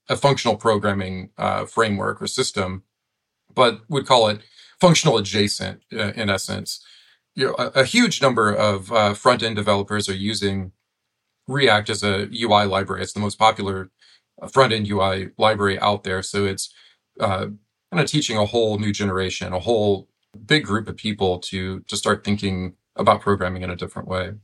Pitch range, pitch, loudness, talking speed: 95-115 Hz, 105 Hz, -21 LUFS, 170 wpm